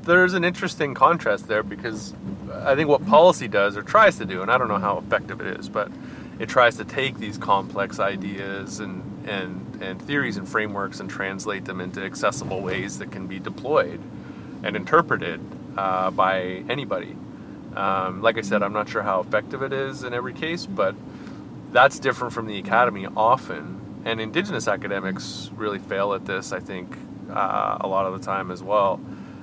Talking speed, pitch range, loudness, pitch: 185 wpm, 95-115 Hz, -23 LUFS, 100 Hz